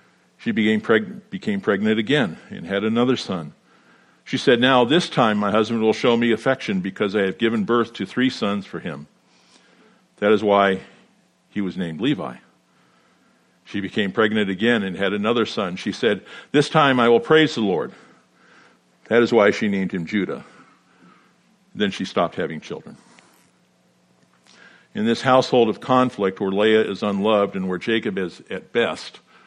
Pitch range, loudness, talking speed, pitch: 95-125 Hz, -20 LUFS, 165 wpm, 110 Hz